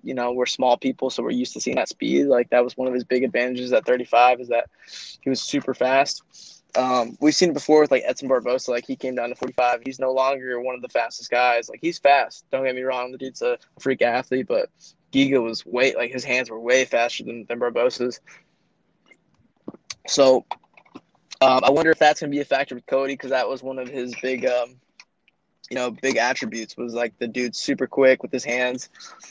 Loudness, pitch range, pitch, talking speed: -22 LUFS, 125-135 Hz, 130 Hz, 225 wpm